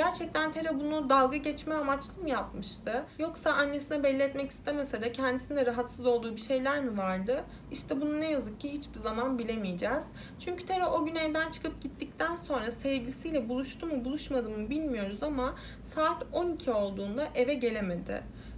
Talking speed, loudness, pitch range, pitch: 160 wpm, -32 LUFS, 245-310 Hz, 275 Hz